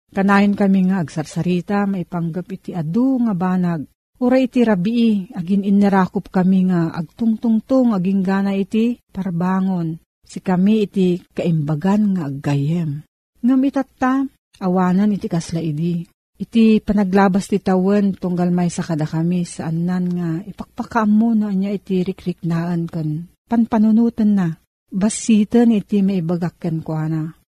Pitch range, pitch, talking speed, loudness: 175-215 Hz, 190 Hz, 125 wpm, -18 LUFS